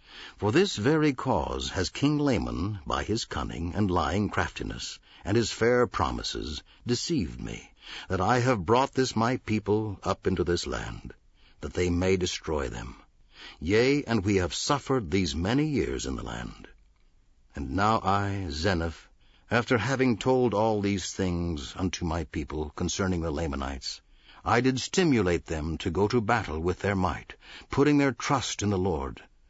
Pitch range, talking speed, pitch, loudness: 85-120 Hz, 160 wpm, 95 Hz, -28 LUFS